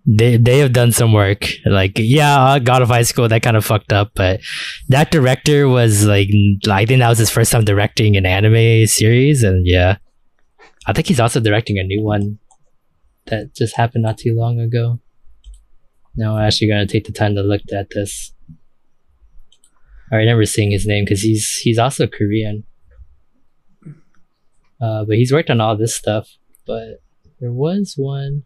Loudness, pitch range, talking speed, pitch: -15 LUFS, 100-120 Hz, 175 wpm, 110 Hz